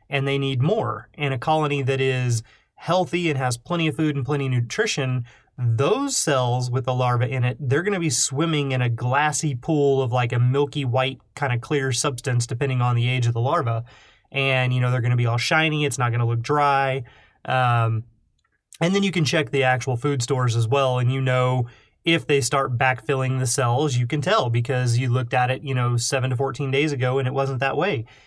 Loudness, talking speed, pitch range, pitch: -22 LUFS, 225 wpm, 125-145 Hz, 130 Hz